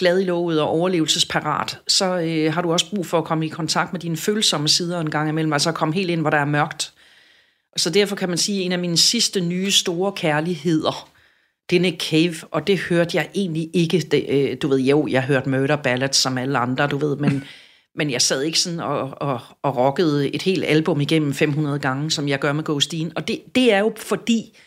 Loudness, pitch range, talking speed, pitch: -20 LUFS, 150-180 Hz, 235 wpm, 165 Hz